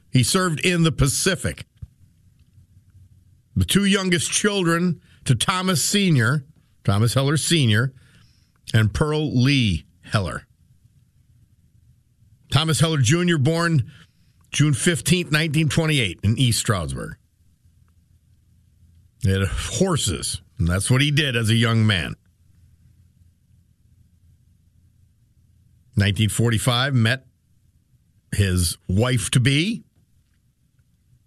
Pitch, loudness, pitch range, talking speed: 115 Hz, -20 LUFS, 95-140 Hz, 90 wpm